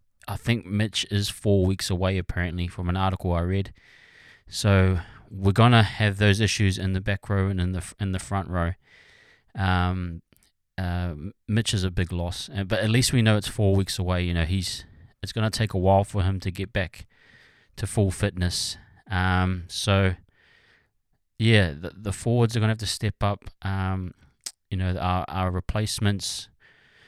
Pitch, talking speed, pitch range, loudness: 95 Hz, 175 wpm, 90-105 Hz, -25 LUFS